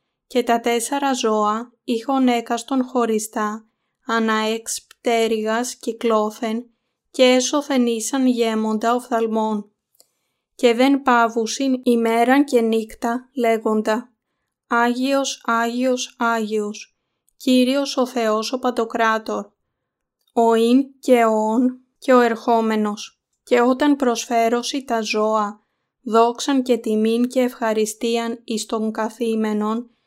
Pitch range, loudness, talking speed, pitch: 220-255 Hz, -20 LUFS, 100 wpm, 235 Hz